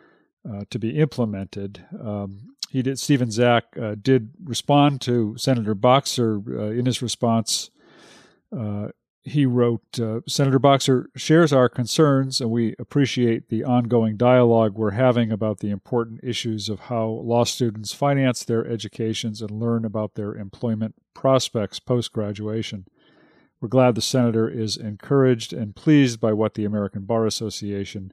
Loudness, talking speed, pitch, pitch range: -22 LUFS, 145 wpm, 115 Hz, 110-130 Hz